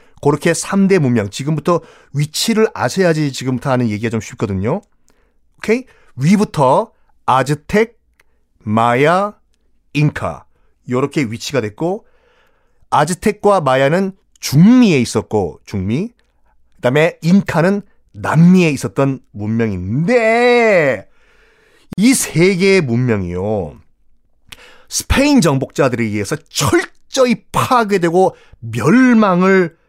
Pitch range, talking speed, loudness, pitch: 115-195 Hz, 225 characters per minute, -15 LUFS, 150 Hz